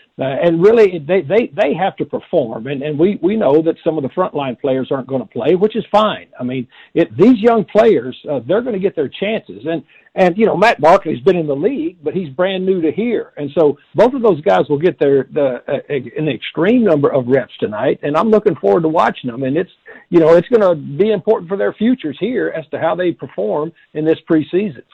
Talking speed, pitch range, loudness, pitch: 250 wpm, 150-210 Hz, -15 LUFS, 175 Hz